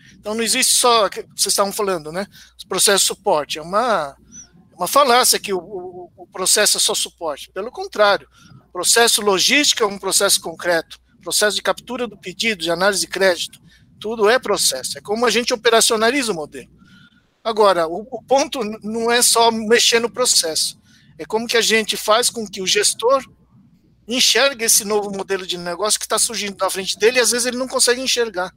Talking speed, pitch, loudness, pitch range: 190 wpm, 210 Hz, -16 LUFS, 190-235 Hz